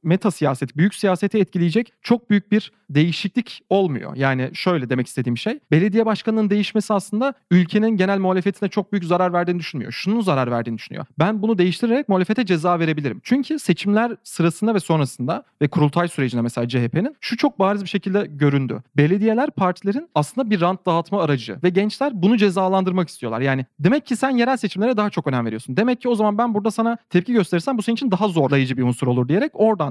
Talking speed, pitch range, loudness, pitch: 190 wpm, 155-220 Hz, -20 LUFS, 190 Hz